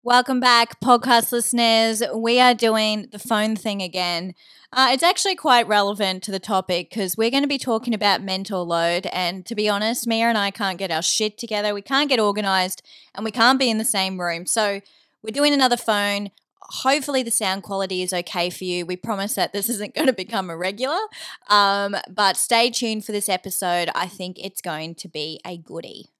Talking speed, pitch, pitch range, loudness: 205 wpm, 210 Hz, 190-235 Hz, -20 LUFS